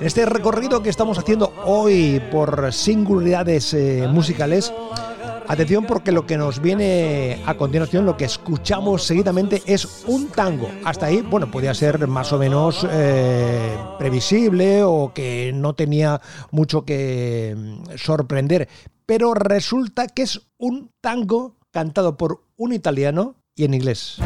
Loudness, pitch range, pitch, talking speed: -19 LUFS, 145-205 Hz, 165 Hz, 140 wpm